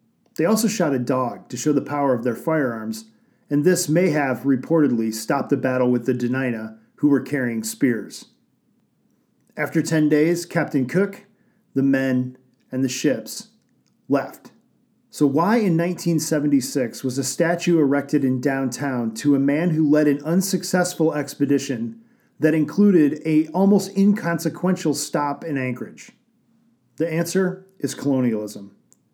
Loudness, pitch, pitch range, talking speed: -21 LUFS, 150 Hz, 135-180 Hz, 140 wpm